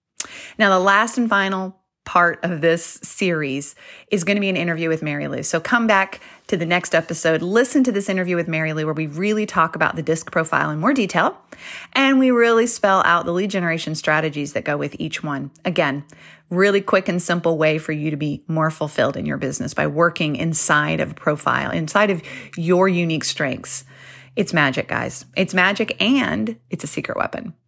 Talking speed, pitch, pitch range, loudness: 200 wpm, 170 Hz, 160-200 Hz, -19 LUFS